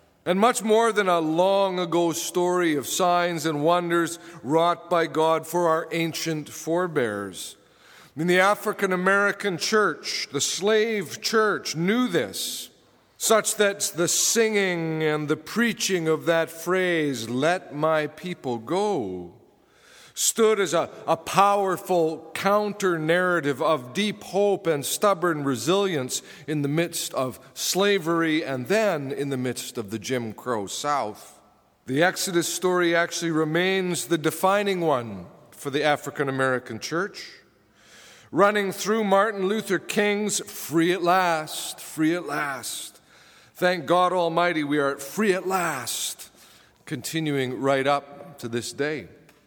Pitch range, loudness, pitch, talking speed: 150-190 Hz, -24 LUFS, 170 Hz, 130 wpm